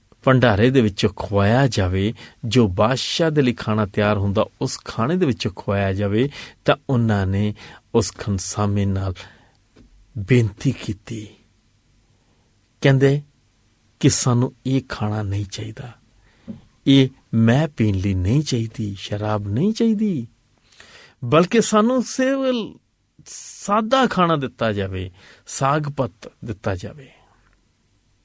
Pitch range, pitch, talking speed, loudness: 105-135 Hz, 115 Hz, 115 wpm, -20 LUFS